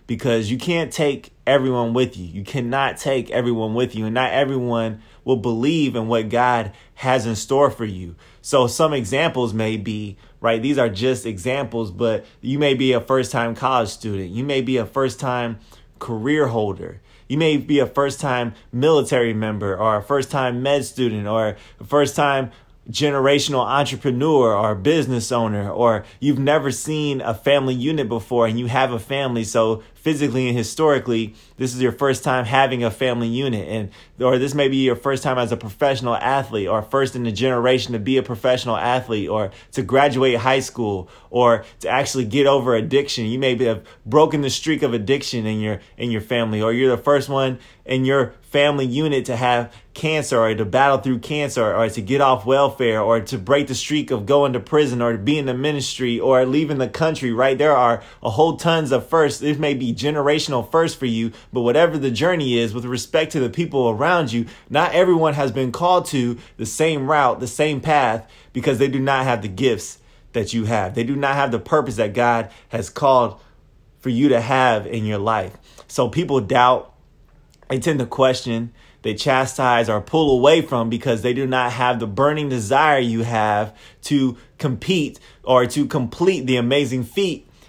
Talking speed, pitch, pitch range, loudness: 195 wpm, 125 Hz, 115-140 Hz, -19 LUFS